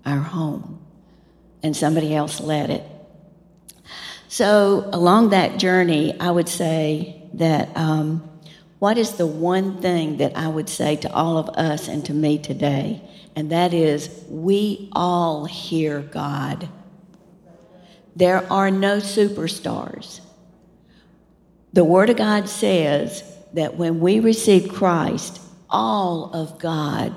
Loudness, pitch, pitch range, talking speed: -20 LUFS, 175 Hz, 155-190 Hz, 125 wpm